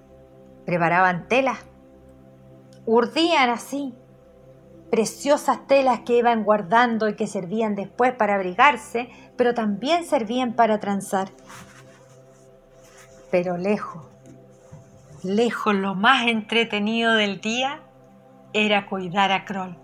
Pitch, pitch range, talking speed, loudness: 210 Hz, 180-235 Hz, 95 wpm, -21 LUFS